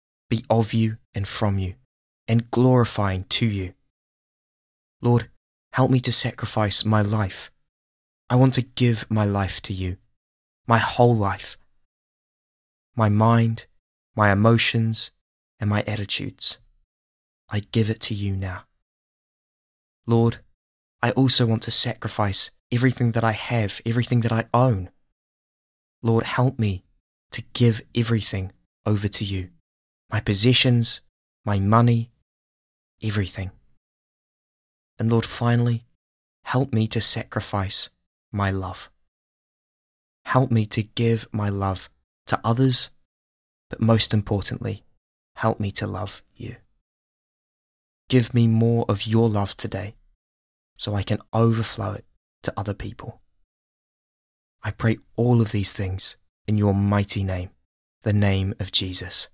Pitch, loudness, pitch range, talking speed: 105 Hz, -21 LUFS, 85-115 Hz, 125 wpm